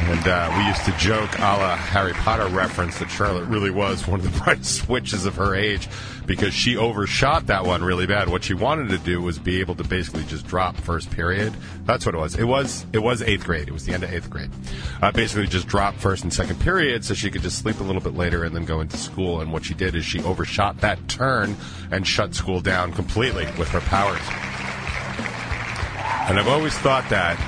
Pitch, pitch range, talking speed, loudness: 90 Hz, 85-100 Hz, 230 wpm, -22 LUFS